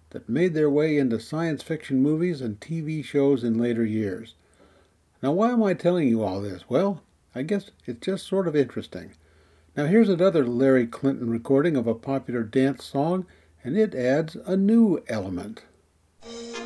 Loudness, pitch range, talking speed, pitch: -24 LUFS, 115-175 Hz, 170 wpm, 140 Hz